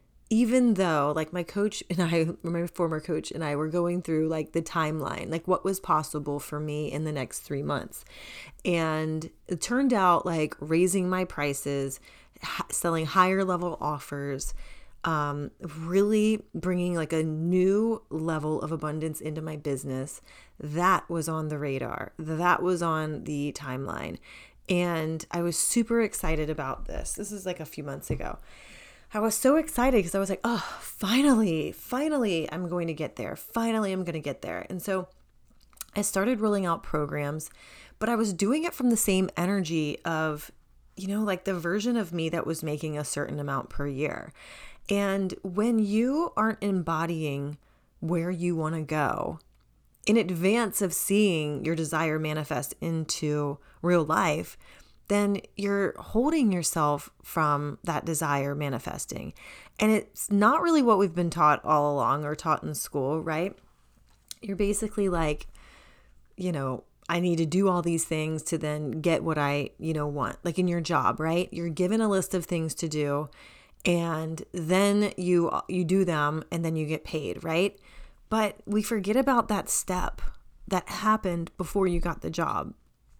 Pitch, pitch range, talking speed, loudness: 170 Hz, 155-195 Hz, 170 wpm, -28 LUFS